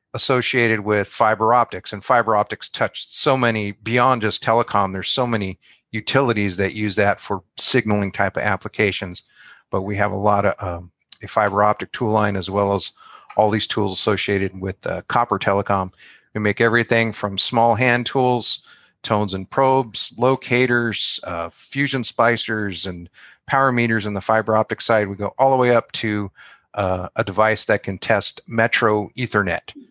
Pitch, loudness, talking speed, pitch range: 105 Hz, -20 LUFS, 170 wpm, 100-120 Hz